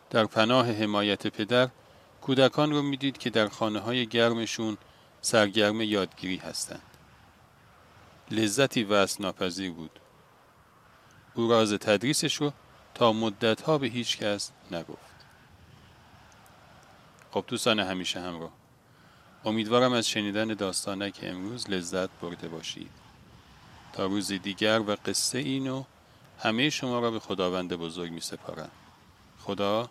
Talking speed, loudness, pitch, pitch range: 110 wpm, -28 LUFS, 110 Hz, 95-125 Hz